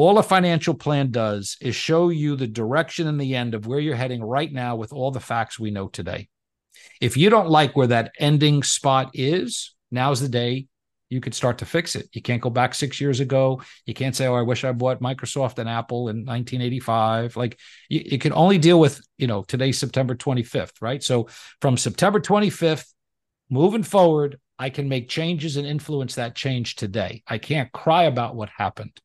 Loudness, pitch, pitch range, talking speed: -22 LUFS, 130 Hz, 120-150 Hz, 200 wpm